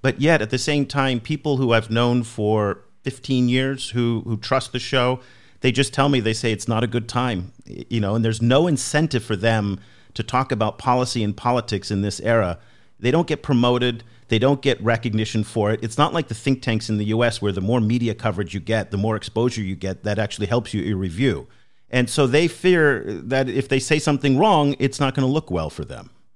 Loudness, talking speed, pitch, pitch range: -21 LUFS, 230 wpm, 120 Hz, 110-135 Hz